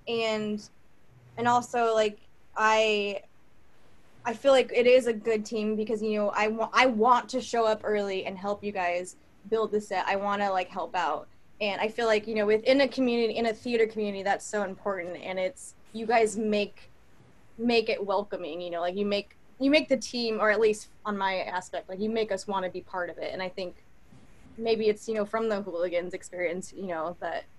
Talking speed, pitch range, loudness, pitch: 220 wpm, 195-225 Hz, -28 LUFS, 215 Hz